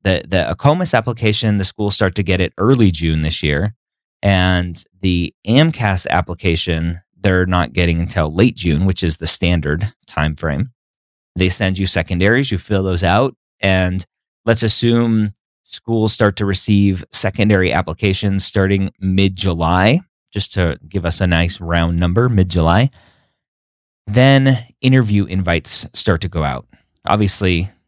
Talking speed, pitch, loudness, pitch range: 145 wpm, 95 Hz, -16 LUFS, 85-105 Hz